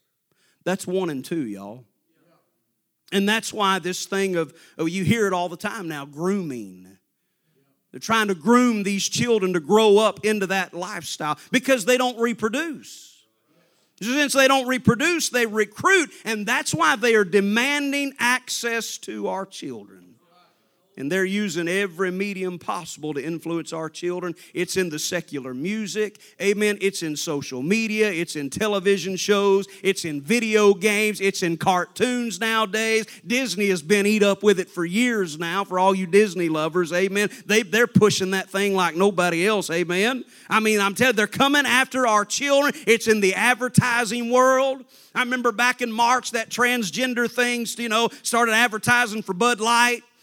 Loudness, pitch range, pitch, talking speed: -21 LUFS, 180-235 Hz, 205 Hz, 165 wpm